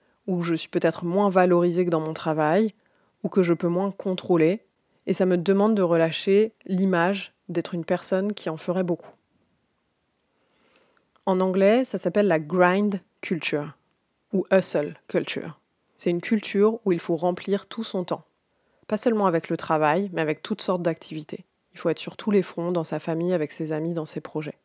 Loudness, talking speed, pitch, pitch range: -24 LUFS, 185 wpm, 180 Hz, 165-195 Hz